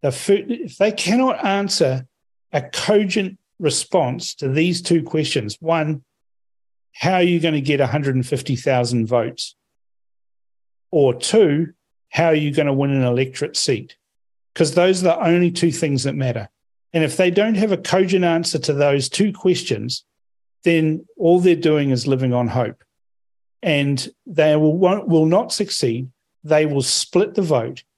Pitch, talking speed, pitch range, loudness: 155 Hz, 160 wpm, 130-175 Hz, -19 LUFS